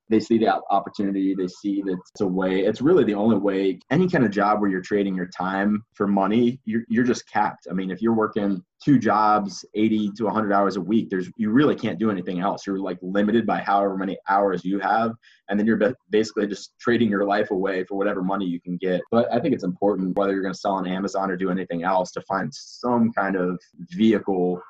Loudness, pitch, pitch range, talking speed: -23 LUFS, 100 Hz, 95-110 Hz, 235 wpm